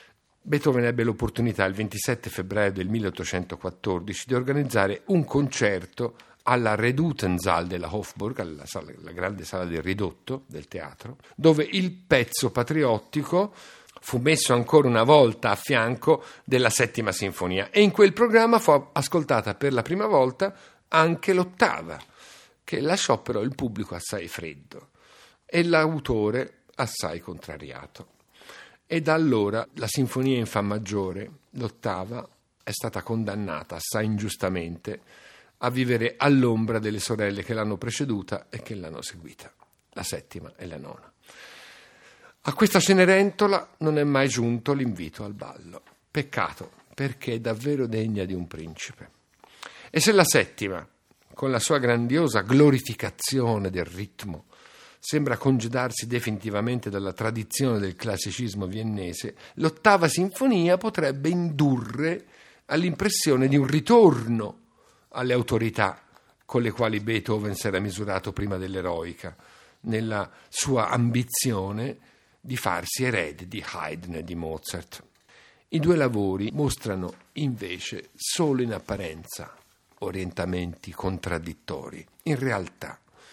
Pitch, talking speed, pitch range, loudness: 115 Hz, 125 wpm, 100-145 Hz, -25 LUFS